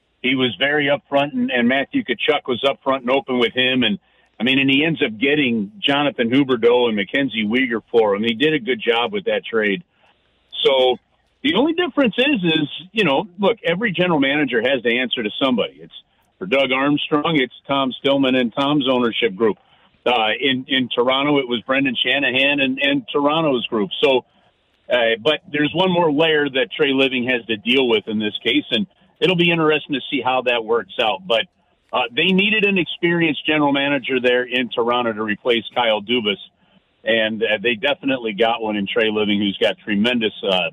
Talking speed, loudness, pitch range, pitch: 195 wpm, -18 LUFS, 125-160 Hz, 140 Hz